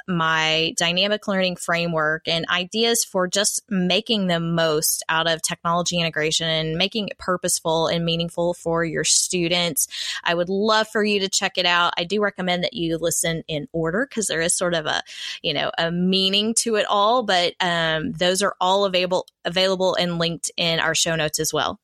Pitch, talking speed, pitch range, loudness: 175 Hz, 190 wpm, 165-190 Hz, -21 LUFS